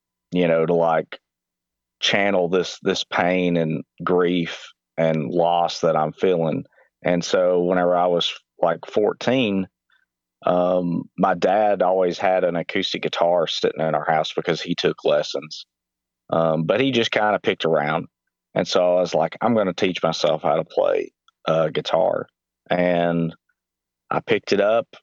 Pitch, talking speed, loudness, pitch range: 85 Hz, 160 wpm, -21 LUFS, 80-90 Hz